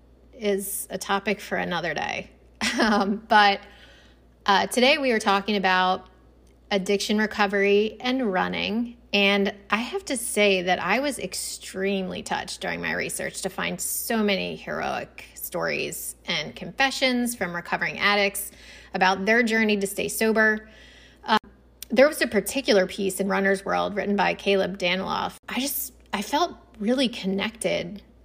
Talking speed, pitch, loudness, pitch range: 140 wpm, 205 Hz, -24 LUFS, 195-225 Hz